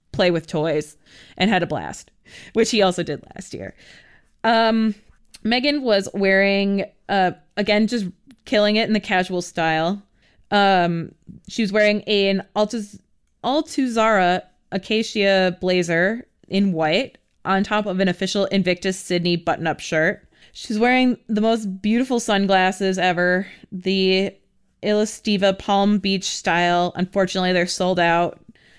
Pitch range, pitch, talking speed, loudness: 180-215 Hz, 195 Hz, 135 wpm, -20 LUFS